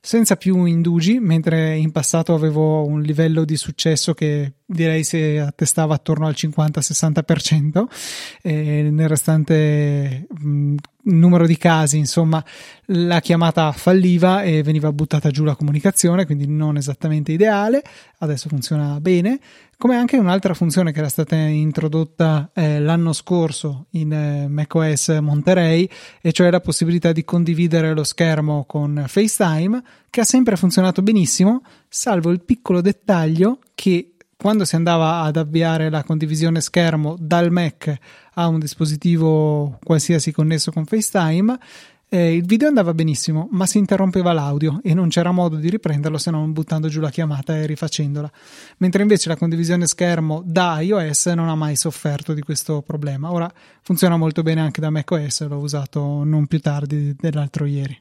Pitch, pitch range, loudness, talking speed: 160 Hz, 155-175 Hz, -18 LUFS, 150 wpm